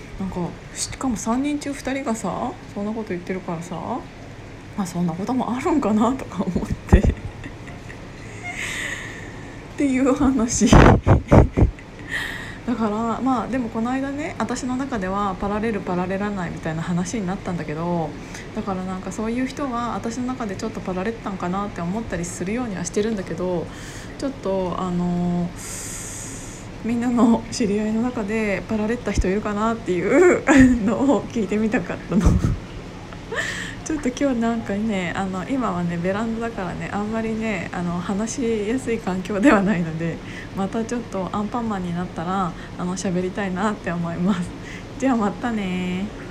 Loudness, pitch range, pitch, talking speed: -23 LUFS, 185-235 Hz, 210 Hz, 330 characters per minute